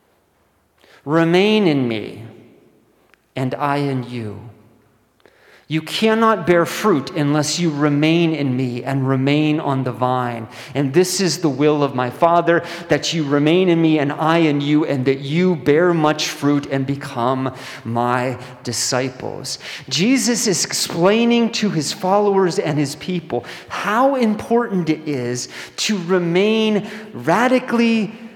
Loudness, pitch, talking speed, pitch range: -18 LUFS, 150 Hz, 135 wpm, 130-185 Hz